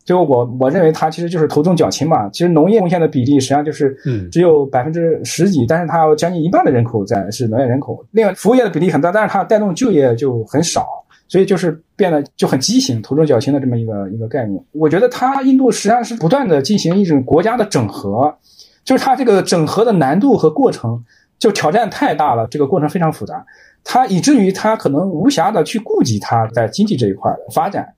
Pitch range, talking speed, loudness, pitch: 135-200 Hz, 360 characters per minute, -14 LUFS, 160 Hz